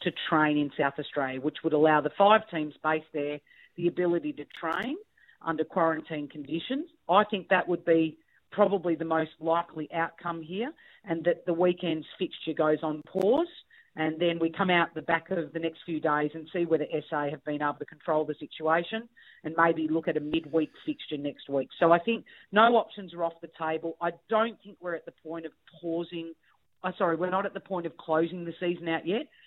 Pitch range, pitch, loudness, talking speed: 155-180 Hz, 165 Hz, -29 LUFS, 210 wpm